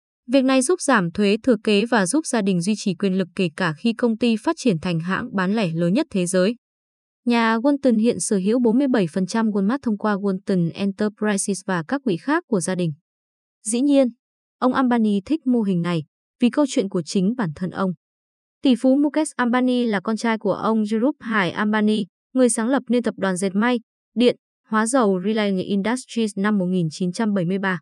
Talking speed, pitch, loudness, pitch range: 195 wpm, 215 Hz, -21 LUFS, 195-245 Hz